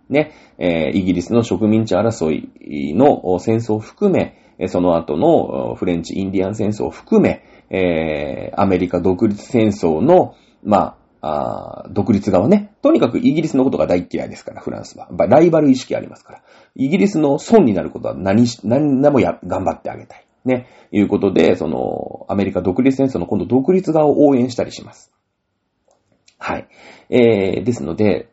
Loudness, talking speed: -17 LUFS, 330 characters per minute